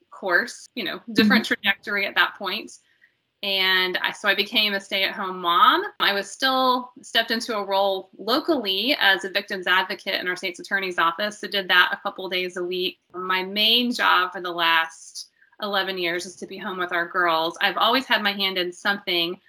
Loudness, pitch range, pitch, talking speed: -22 LUFS, 180-215 Hz, 195 Hz, 200 wpm